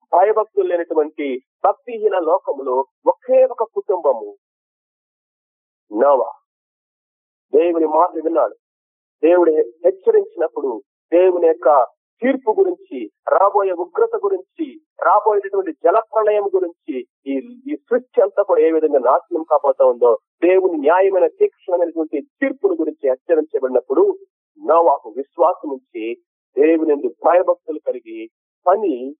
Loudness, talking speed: -17 LUFS, 90 wpm